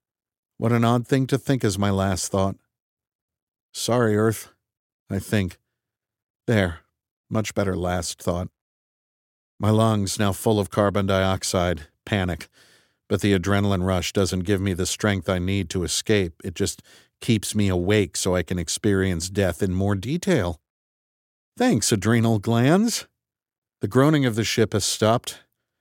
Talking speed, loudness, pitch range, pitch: 145 wpm, -23 LUFS, 95-110 Hz, 100 Hz